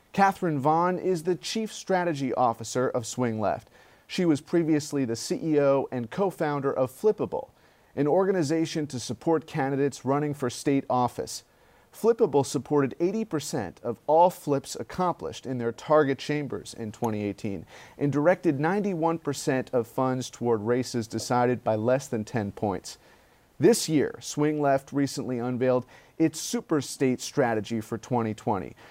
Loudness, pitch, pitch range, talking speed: -27 LUFS, 140 Hz, 120-160 Hz, 140 wpm